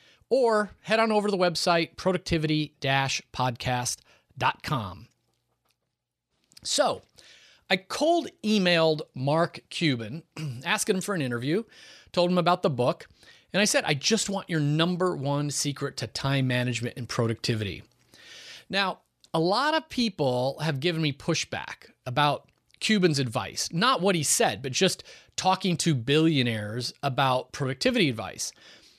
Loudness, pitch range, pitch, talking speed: -26 LUFS, 130-185 Hz, 155 Hz, 130 wpm